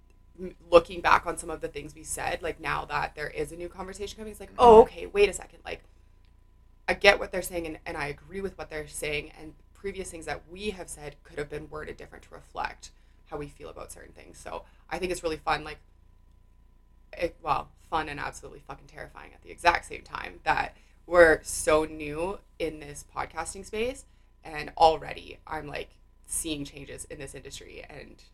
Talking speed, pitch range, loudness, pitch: 205 wpm, 140-180 Hz, -27 LUFS, 155 Hz